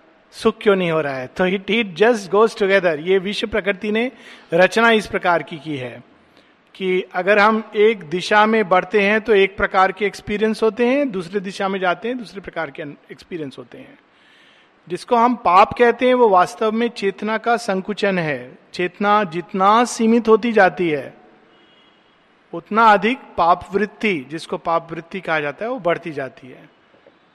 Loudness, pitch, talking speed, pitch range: -18 LUFS, 200 Hz, 170 wpm, 180-220 Hz